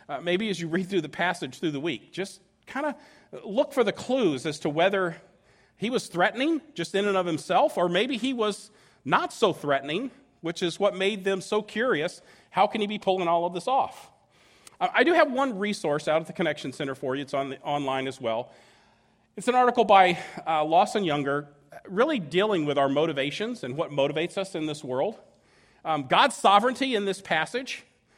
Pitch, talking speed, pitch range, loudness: 185 Hz, 205 wpm, 155-215 Hz, -26 LUFS